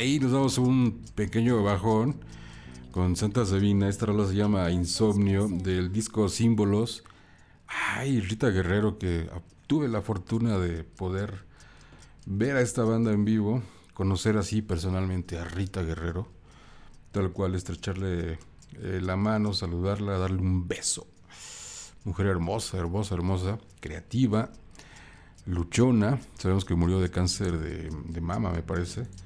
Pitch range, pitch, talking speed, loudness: 90-110 Hz, 95 Hz, 130 wpm, -28 LUFS